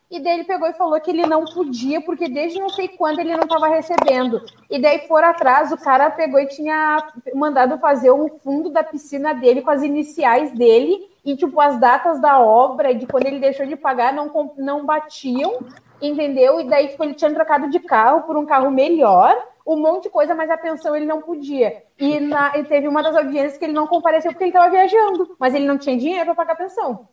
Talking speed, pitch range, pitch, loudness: 225 wpm, 275-325 Hz, 300 Hz, -17 LUFS